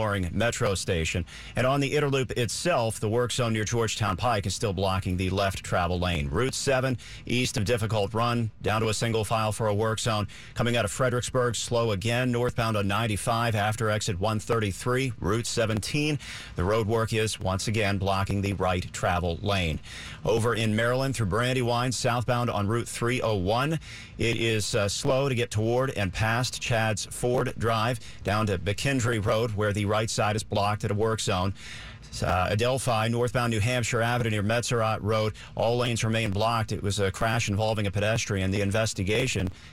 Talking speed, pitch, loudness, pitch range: 175 wpm, 110 Hz, -27 LUFS, 100-120 Hz